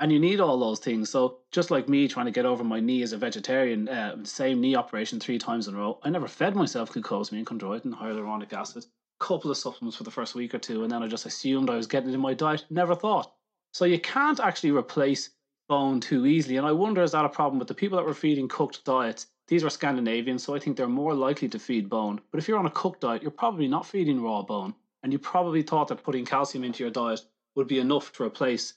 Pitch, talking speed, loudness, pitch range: 135 Hz, 255 wpm, -27 LUFS, 120-160 Hz